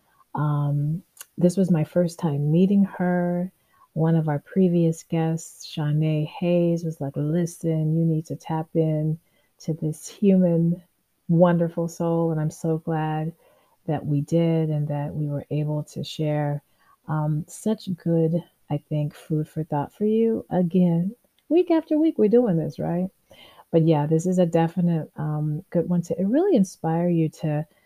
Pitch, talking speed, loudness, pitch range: 165 Hz, 160 wpm, -24 LUFS, 155-175 Hz